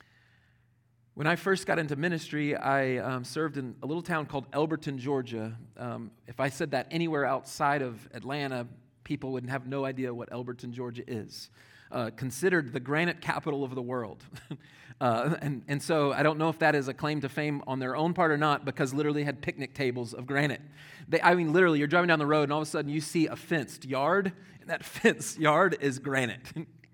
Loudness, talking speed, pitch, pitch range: -30 LUFS, 210 wpm, 140 Hz, 130-155 Hz